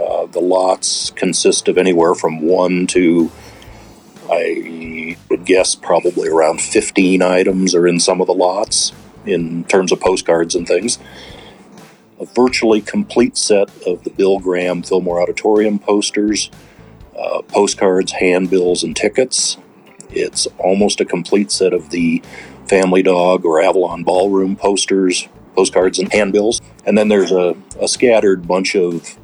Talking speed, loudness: 140 wpm, -14 LUFS